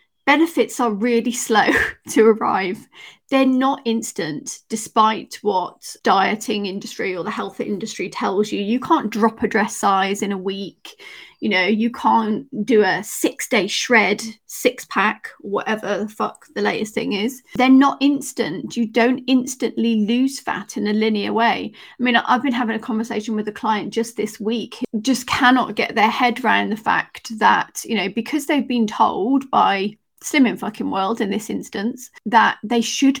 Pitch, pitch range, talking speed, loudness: 230 Hz, 215-250 Hz, 175 wpm, -19 LUFS